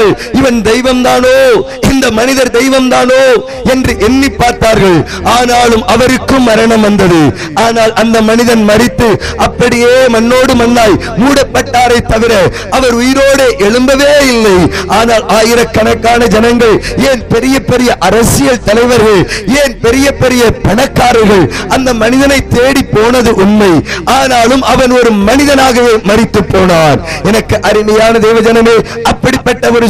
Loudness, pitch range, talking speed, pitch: -7 LUFS, 220-255 Hz, 110 wpm, 235 Hz